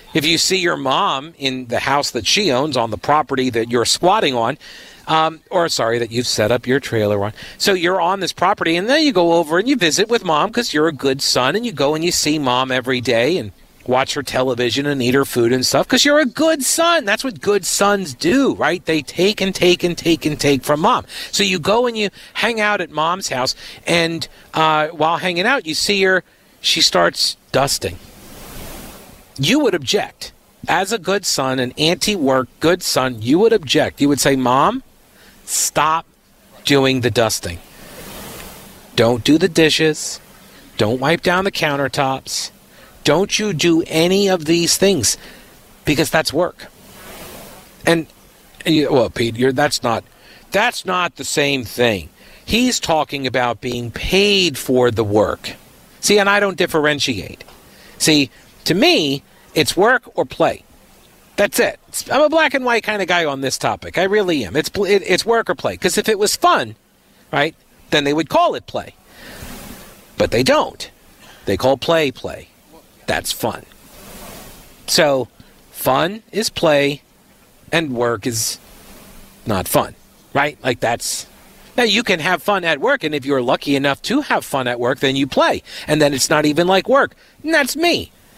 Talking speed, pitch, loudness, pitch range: 180 wpm, 155 Hz, -17 LUFS, 130-195 Hz